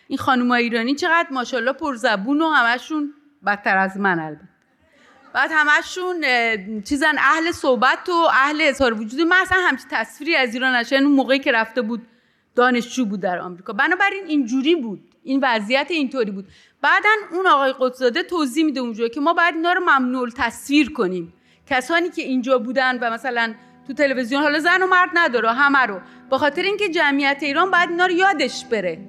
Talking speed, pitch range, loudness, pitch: 170 wpm, 245-320 Hz, -19 LUFS, 270 Hz